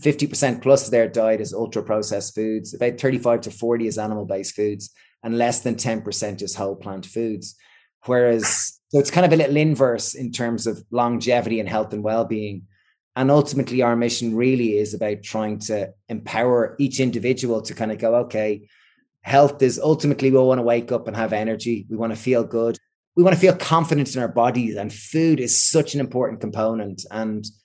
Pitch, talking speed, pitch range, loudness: 115 Hz, 195 wpm, 110-130 Hz, -21 LUFS